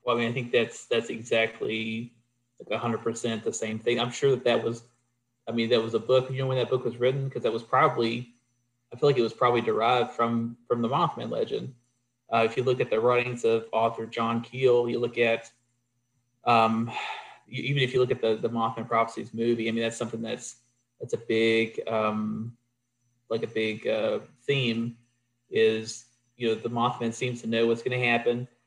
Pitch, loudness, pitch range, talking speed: 120 Hz, -27 LUFS, 115-120 Hz, 205 wpm